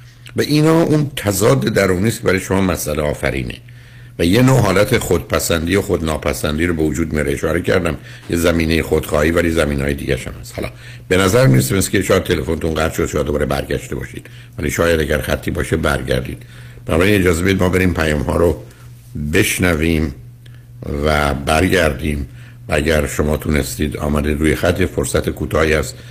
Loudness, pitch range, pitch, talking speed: -16 LUFS, 75-115 Hz, 85 Hz, 165 wpm